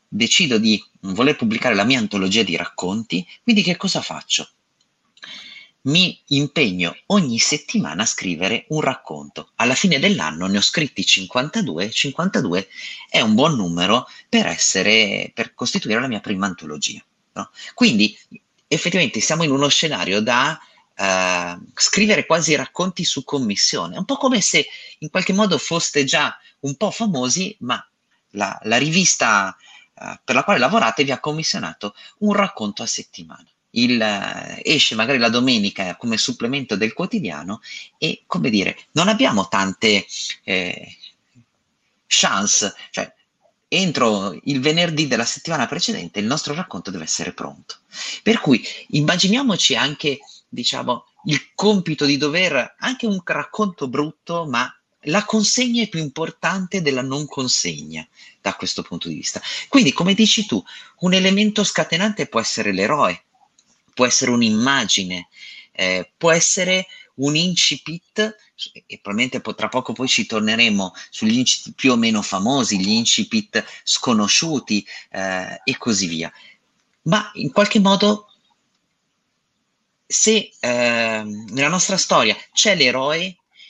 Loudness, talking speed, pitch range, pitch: -18 LUFS, 135 wpm, 125-210 Hz, 165 Hz